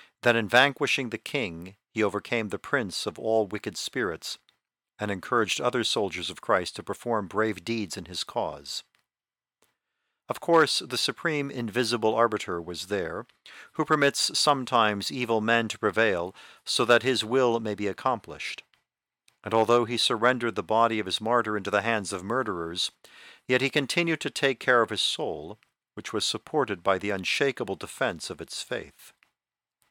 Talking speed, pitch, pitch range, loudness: 165 wpm, 115 Hz, 105-125 Hz, -26 LUFS